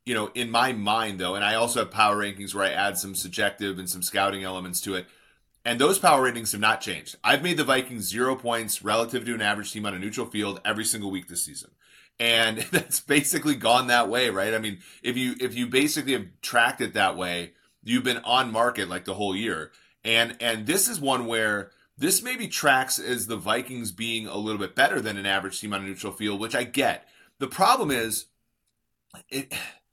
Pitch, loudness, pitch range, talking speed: 110 Hz, -25 LUFS, 100-120 Hz, 220 wpm